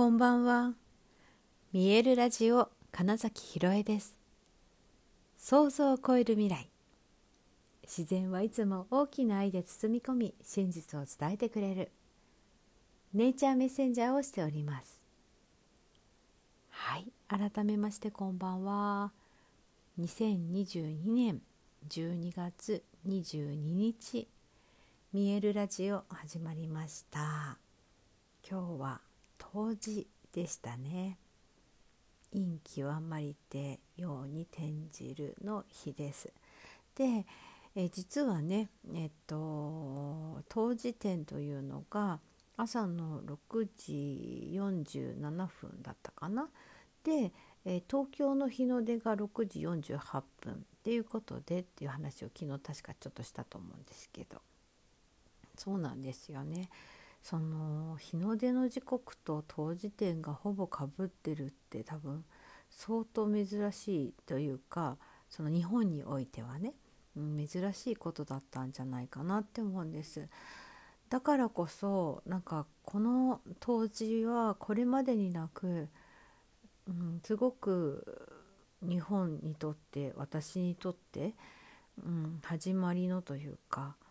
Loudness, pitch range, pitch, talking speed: -36 LUFS, 155-220 Hz, 185 Hz, 215 characters per minute